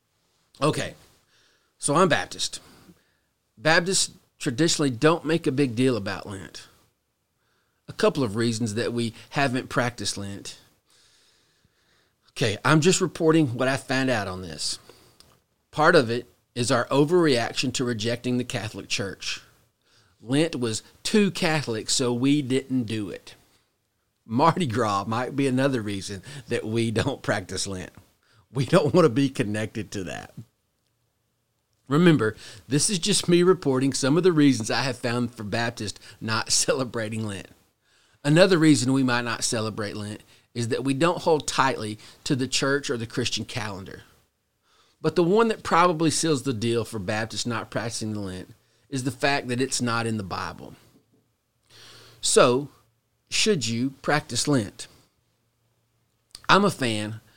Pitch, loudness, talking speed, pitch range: 120 Hz, -24 LUFS, 145 wpm, 110-140 Hz